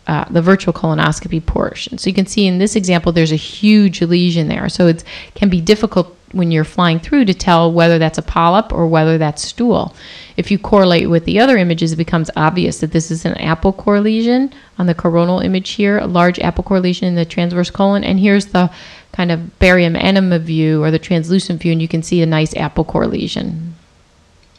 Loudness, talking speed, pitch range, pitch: -14 LUFS, 215 wpm, 165-195 Hz, 175 Hz